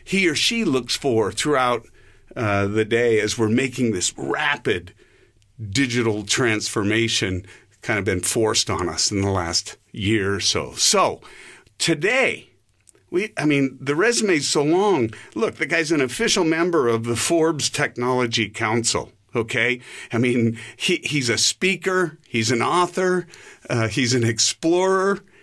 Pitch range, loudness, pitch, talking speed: 110-155 Hz, -20 LUFS, 120 Hz, 145 wpm